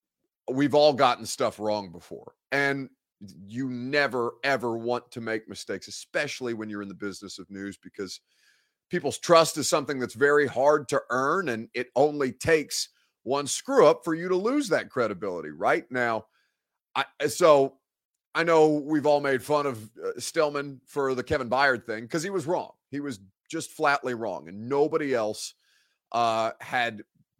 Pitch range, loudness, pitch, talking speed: 115-150 Hz, -26 LUFS, 135 Hz, 165 wpm